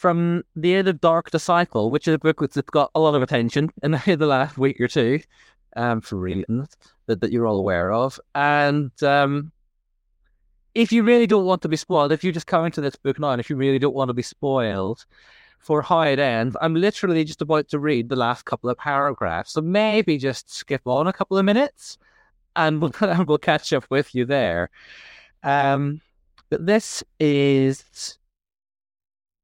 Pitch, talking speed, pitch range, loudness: 145 Hz, 200 wpm, 130-170 Hz, -21 LUFS